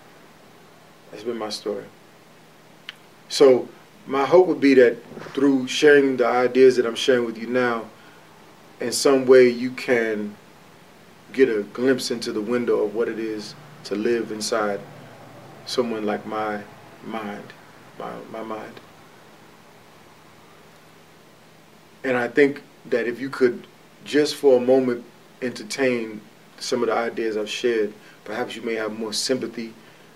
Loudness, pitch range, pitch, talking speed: -21 LUFS, 110-130 Hz, 120 Hz, 135 wpm